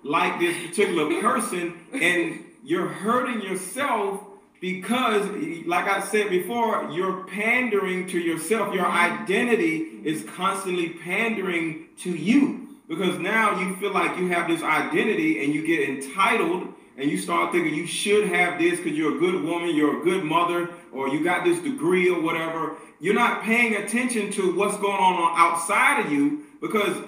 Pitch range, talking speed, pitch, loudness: 175-240 Hz, 160 wpm, 195 Hz, -23 LUFS